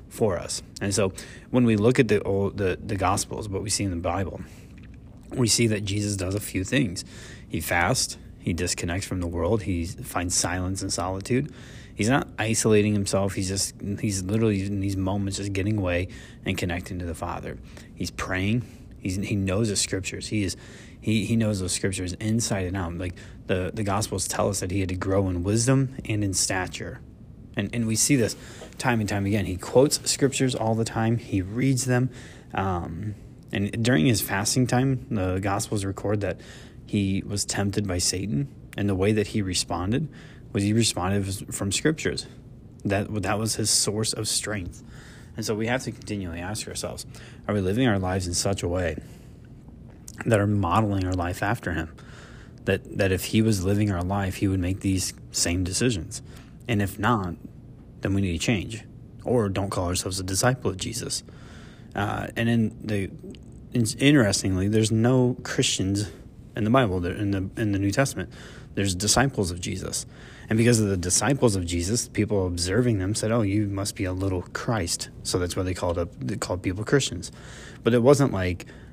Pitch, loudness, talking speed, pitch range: 105 Hz, -25 LUFS, 190 wpm, 95-115 Hz